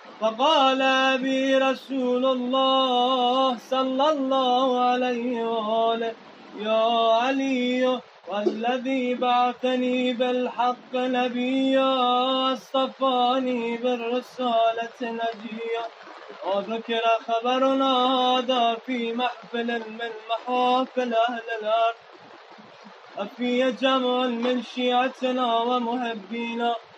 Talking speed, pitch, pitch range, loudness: 70 wpm, 250 Hz, 230-260 Hz, -24 LUFS